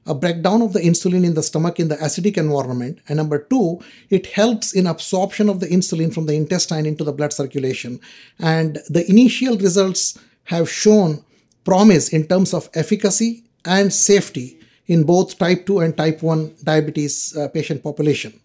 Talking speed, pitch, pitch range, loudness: 170 wpm, 170 Hz, 155-195 Hz, -17 LUFS